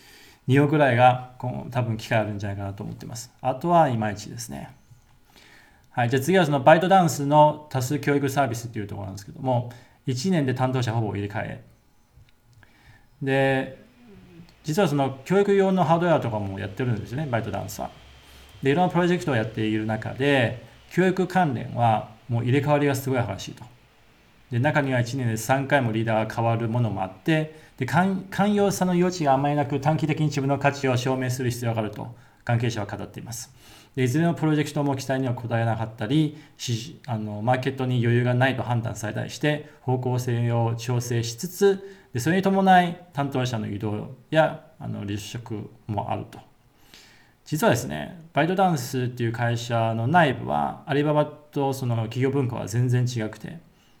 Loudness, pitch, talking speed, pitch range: -24 LUFS, 130 Hz, 365 characters per minute, 115-150 Hz